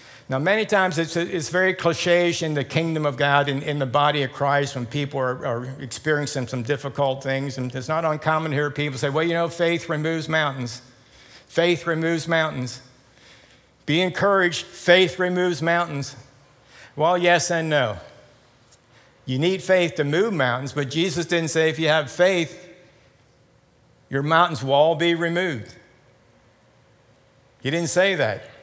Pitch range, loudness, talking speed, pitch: 135-170 Hz, -22 LUFS, 160 wpm, 155 Hz